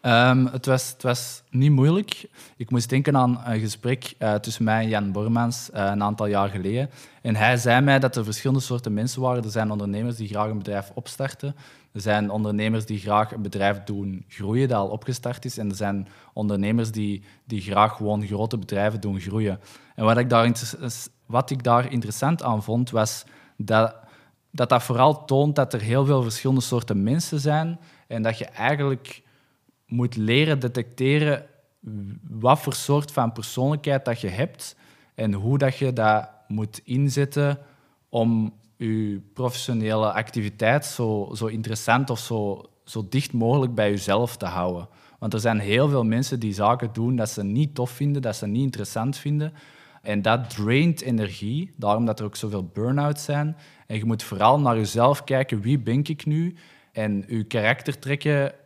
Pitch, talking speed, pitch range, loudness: 120 Hz, 180 wpm, 110-135 Hz, -24 LUFS